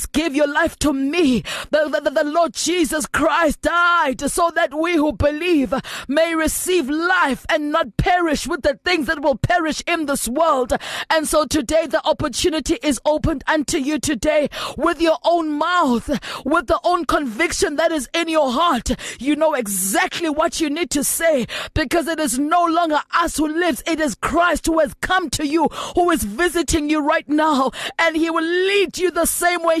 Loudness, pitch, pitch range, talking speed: -19 LUFS, 315 Hz, 295-335 Hz, 185 wpm